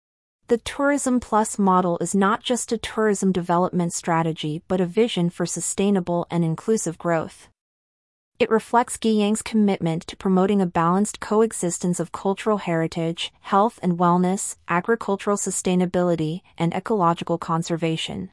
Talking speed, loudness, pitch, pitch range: 130 wpm, -22 LUFS, 185 Hz, 170-215 Hz